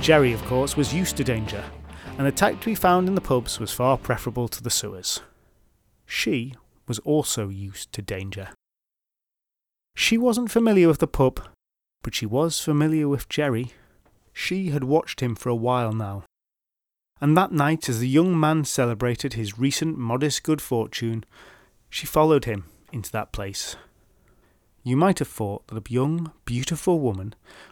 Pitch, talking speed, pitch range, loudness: 125 Hz, 165 wpm, 110-155 Hz, -24 LUFS